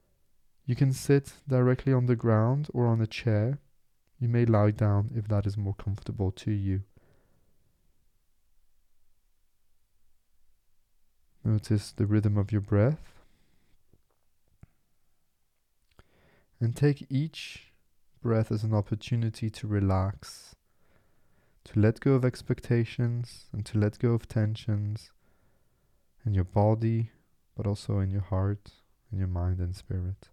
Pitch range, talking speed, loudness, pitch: 100-120 Hz, 120 wpm, -29 LUFS, 110 Hz